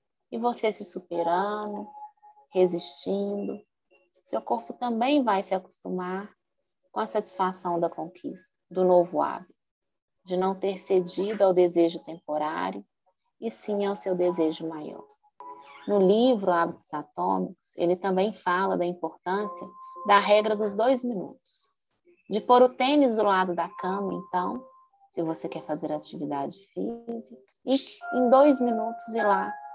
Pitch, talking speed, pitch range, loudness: 195 Hz, 135 wpm, 175-235 Hz, -26 LUFS